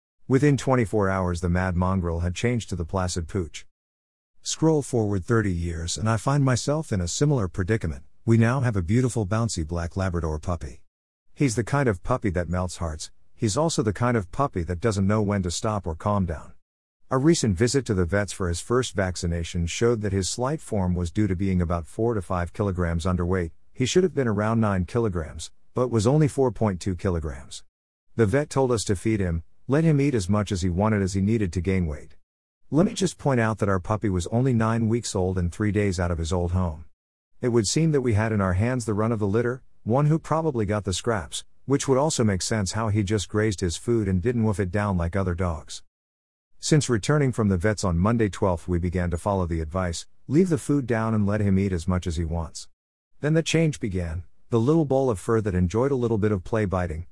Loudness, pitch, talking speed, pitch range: -25 LUFS, 100 Hz, 230 wpm, 90-120 Hz